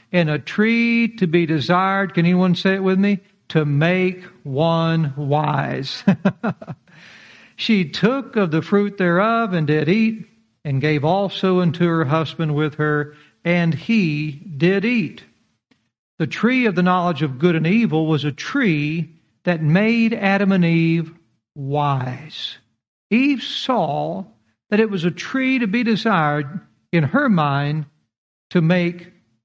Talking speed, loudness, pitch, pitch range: 145 wpm, -19 LUFS, 175 Hz, 155-200 Hz